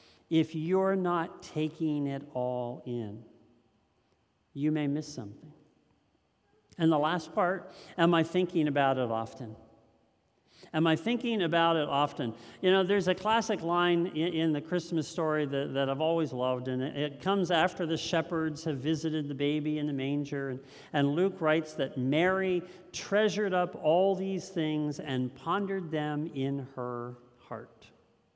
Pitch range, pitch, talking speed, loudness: 135-175 Hz, 155 Hz, 155 wpm, -30 LUFS